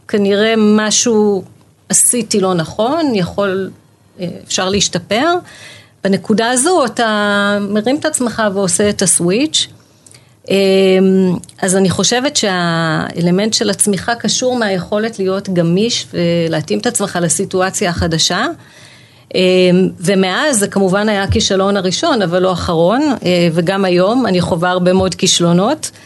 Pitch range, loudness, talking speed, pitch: 180-215 Hz, -13 LUFS, 110 wpm, 195 Hz